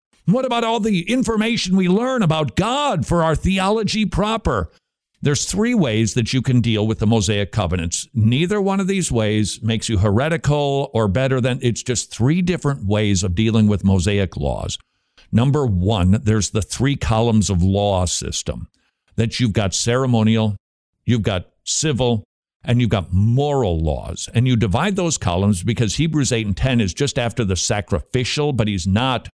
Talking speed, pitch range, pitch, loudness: 170 wpm, 105-150 Hz, 115 Hz, -19 LUFS